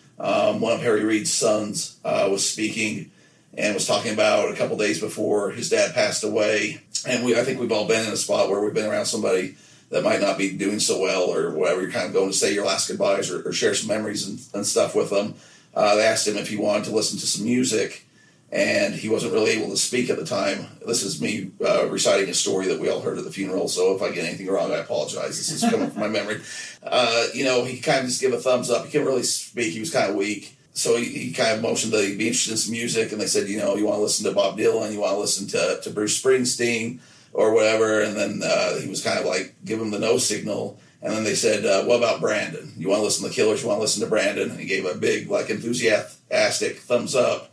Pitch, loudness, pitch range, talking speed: 110 Hz, -22 LUFS, 105-130 Hz, 270 wpm